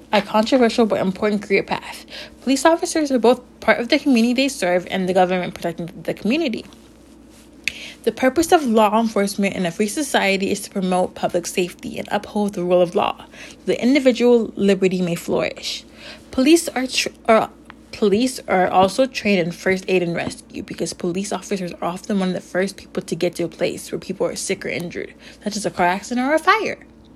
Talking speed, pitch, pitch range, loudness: 200 wpm, 210 Hz, 185-255 Hz, -20 LUFS